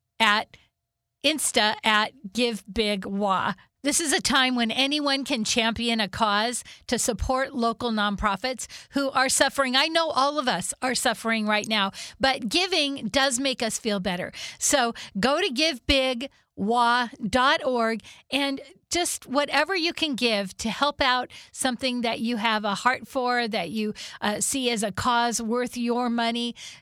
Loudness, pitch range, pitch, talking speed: -24 LUFS, 225-275 Hz, 245 Hz, 150 wpm